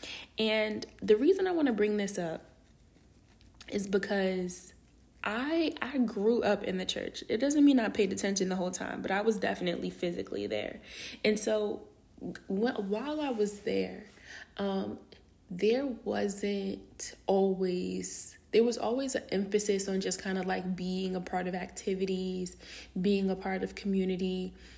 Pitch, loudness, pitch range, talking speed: 200 Hz, -31 LUFS, 185-220 Hz, 155 wpm